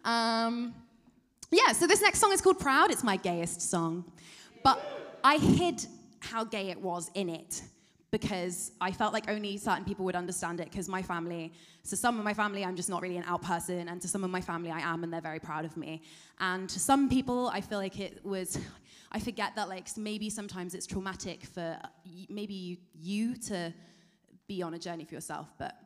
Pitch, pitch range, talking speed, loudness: 185 Hz, 170-215 Hz, 205 wpm, -31 LUFS